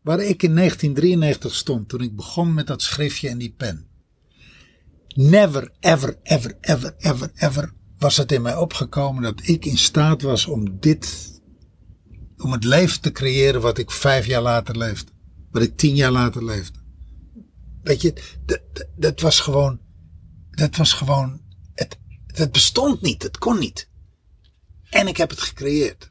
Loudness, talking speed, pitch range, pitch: -19 LUFS, 165 wpm, 95-150 Hz, 130 Hz